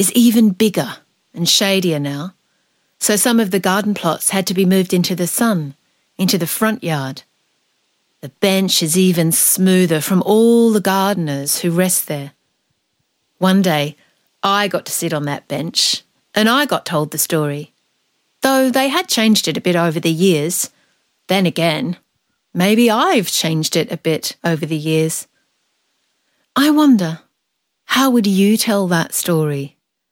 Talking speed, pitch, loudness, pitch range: 155 wpm, 185 Hz, -16 LUFS, 160-210 Hz